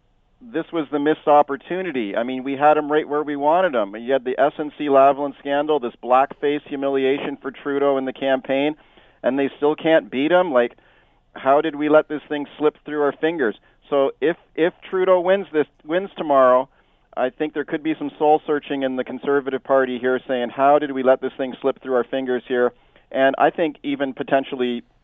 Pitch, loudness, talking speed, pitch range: 140 Hz, -20 LUFS, 200 wpm, 130-150 Hz